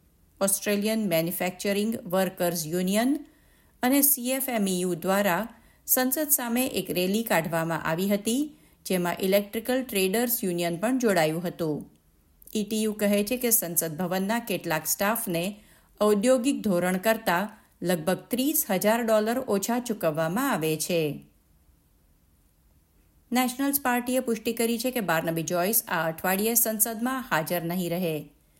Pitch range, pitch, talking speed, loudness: 170-230 Hz, 200 Hz, 115 wpm, -26 LUFS